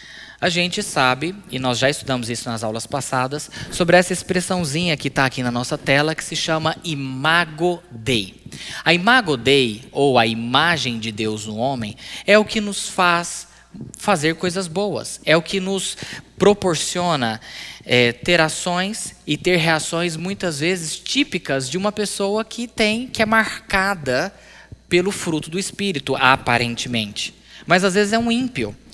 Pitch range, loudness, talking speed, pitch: 130-190 Hz, -19 LUFS, 160 wpm, 165 Hz